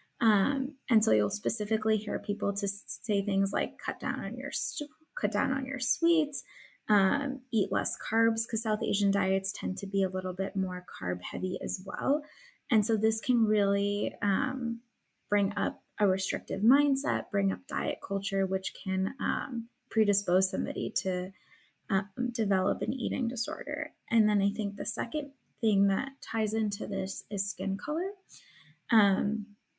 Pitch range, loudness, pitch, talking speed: 195-235 Hz, -29 LUFS, 210 Hz, 160 wpm